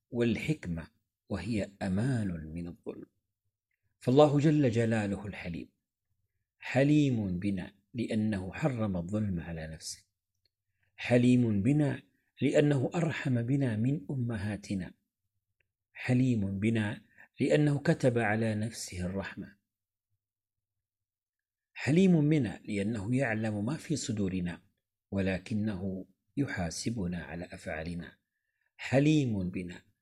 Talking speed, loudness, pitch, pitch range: 85 wpm, -31 LUFS, 105 Hz, 95-125 Hz